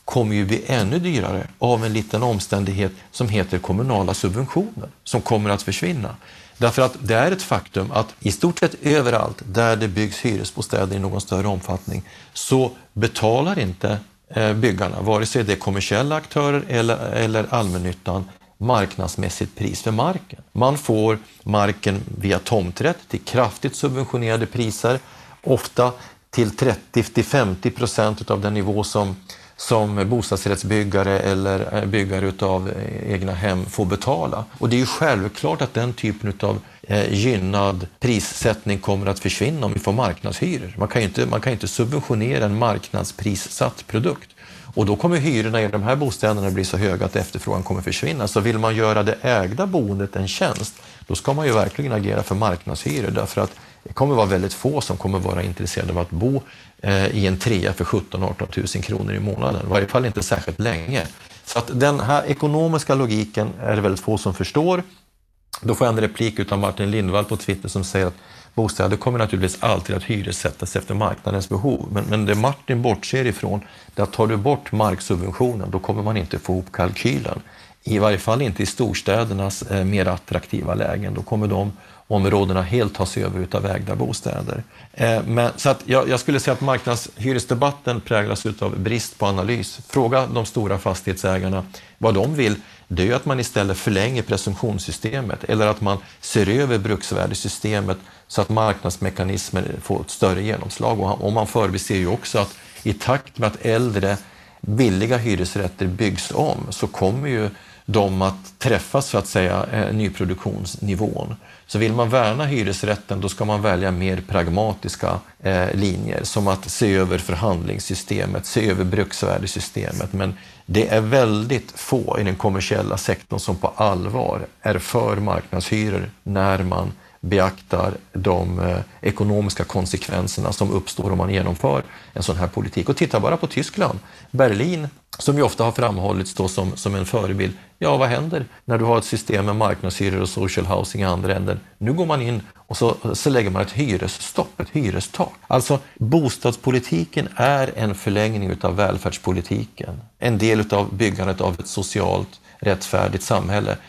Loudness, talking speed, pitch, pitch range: -21 LUFS, 160 wpm, 105 Hz, 95-115 Hz